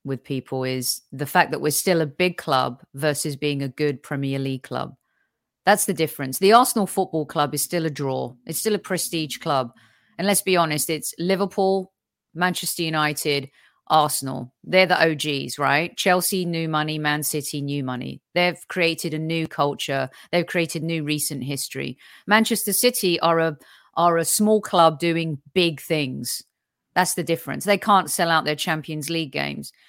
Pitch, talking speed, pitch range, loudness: 160 Hz, 175 wpm, 145-180 Hz, -22 LUFS